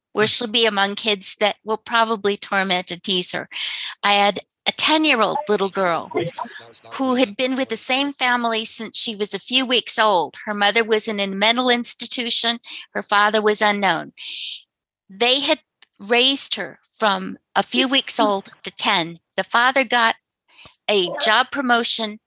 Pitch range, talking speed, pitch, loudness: 200-245 Hz, 165 wpm, 220 Hz, -18 LUFS